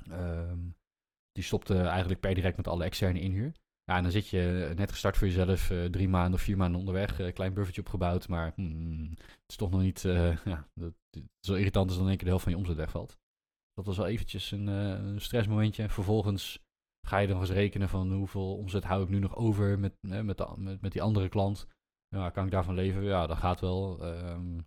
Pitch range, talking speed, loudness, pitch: 90-100 Hz, 235 wpm, -32 LUFS, 95 Hz